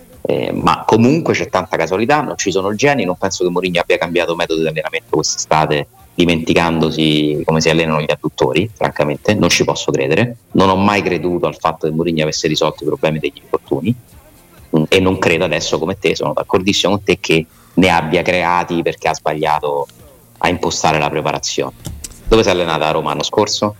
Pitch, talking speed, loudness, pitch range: 85 Hz, 185 wpm, -15 LUFS, 80-95 Hz